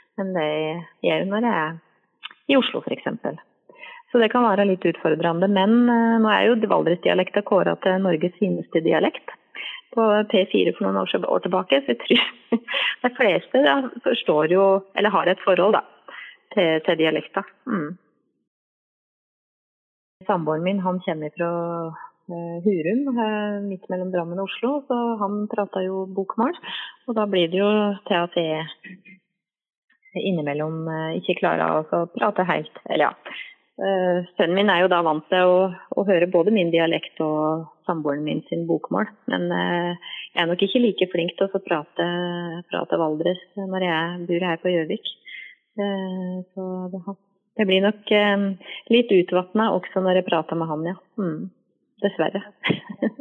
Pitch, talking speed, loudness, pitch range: 185 Hz, 155 wpm, -22 LUFS, 170-205 Hz